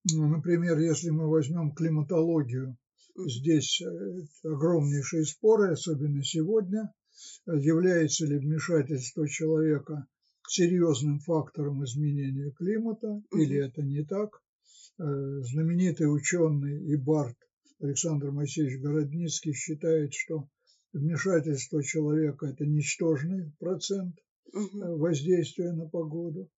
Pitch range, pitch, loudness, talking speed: 145-170 Hz, 155 Hz, -29 LUFS, 90 wpm